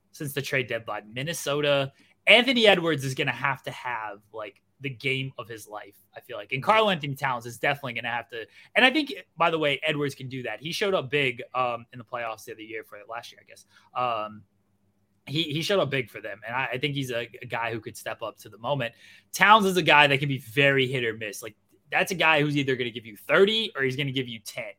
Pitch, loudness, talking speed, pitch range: 135 Hz, -25 LUFS, 265 wpm, 115-155 Hz